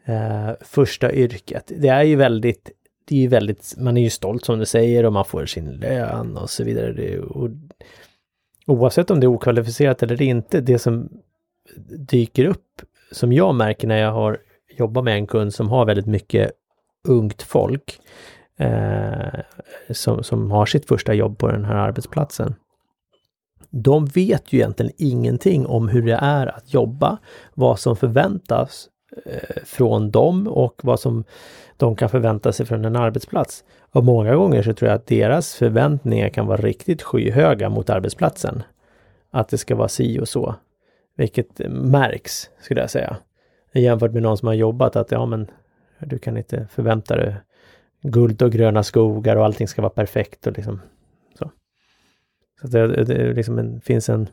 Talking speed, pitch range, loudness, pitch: 170 wpm, 110-130 Hz, -19 LUFS, 115 Hz